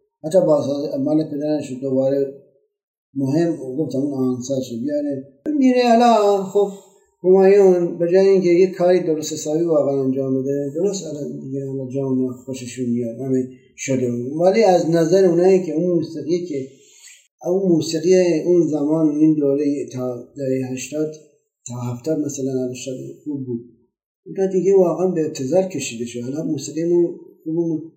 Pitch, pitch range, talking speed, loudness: 155 Hz, 135-180 Hz, 150 wpm, -19 LUFS